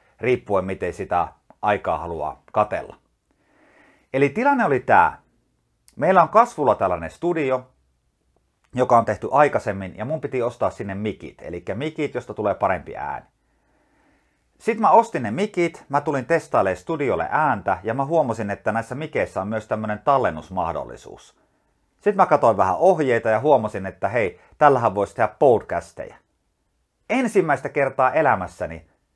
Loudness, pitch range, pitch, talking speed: -21 LUFS, 110-160 Hz, 130 Hz, 140 wpm